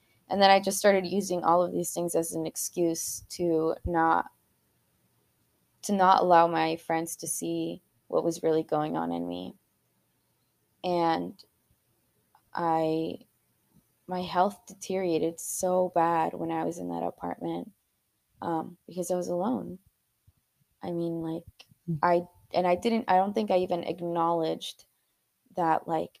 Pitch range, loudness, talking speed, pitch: 160-180 Hz, -28 LUFS, 140 wpm, 170 Hz